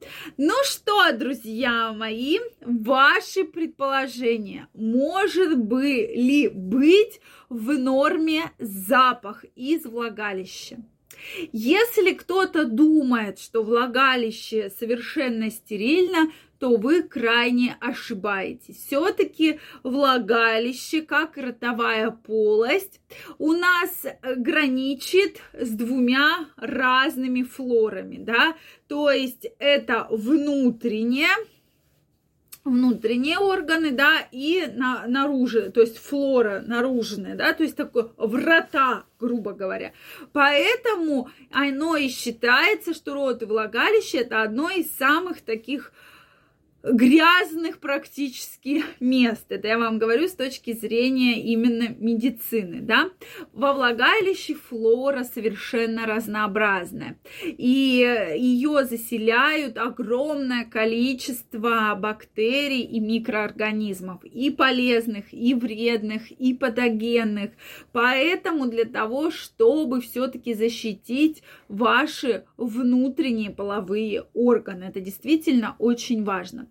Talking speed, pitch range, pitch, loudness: 95 wpm, 230-300 Hz, 255 Hz, -22 LUFS